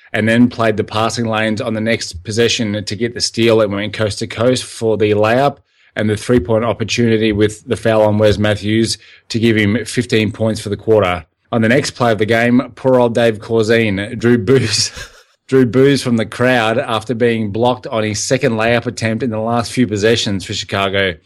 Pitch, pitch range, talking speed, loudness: 110 Hz, 105-120 Hz, 210 wpm, -15 LUFS